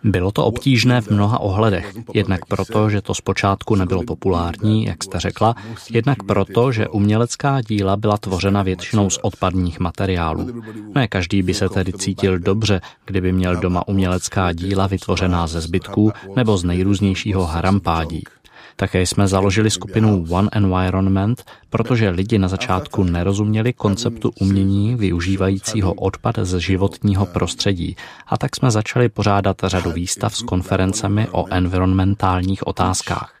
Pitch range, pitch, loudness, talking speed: 95-110 Hz, 95 Hz, -19 LUFS, 135 wpm